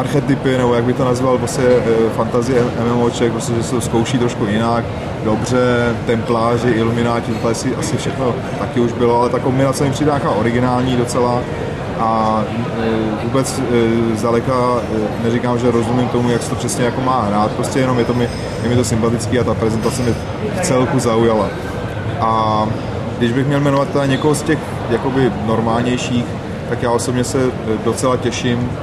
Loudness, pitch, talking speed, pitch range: -16 LUFS, 120 Hz, 165 wpm, 115-125 Hz